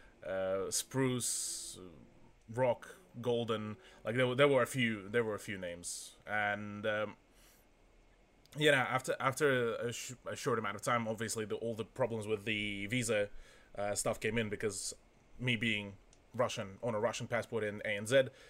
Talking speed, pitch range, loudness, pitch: 160 wpm, 105-120 Hz, -35 LUFS, 110 Hz